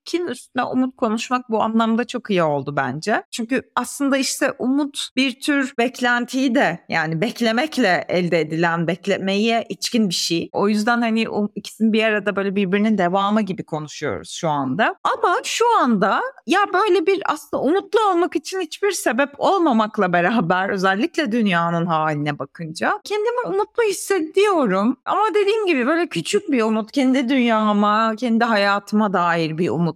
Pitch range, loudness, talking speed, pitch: 195-295 Hz, -19 LUFS, 145 wpm, 235 Hz